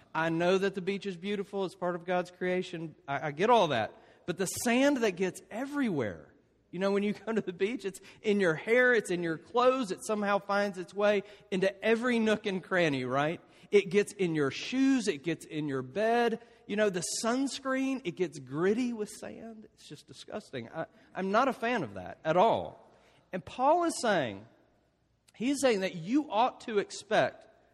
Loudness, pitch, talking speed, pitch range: -30 LUFS, 200 Hz, 200 wpm, 175-225 Hz